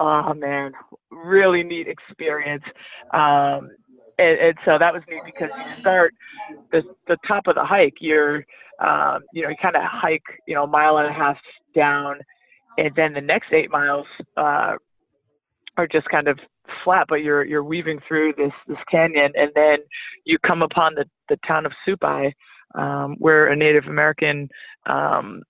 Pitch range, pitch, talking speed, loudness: 145-170 Hz, 155 Hz, 170 wpm, -20 LUFS